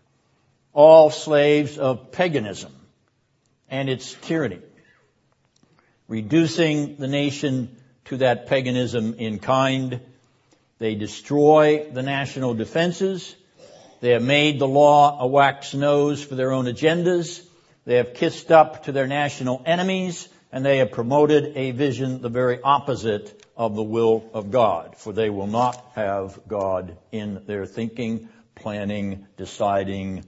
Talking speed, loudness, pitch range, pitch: 130 wpm, -21 LUFS, 115-145 Hz, 130 Hz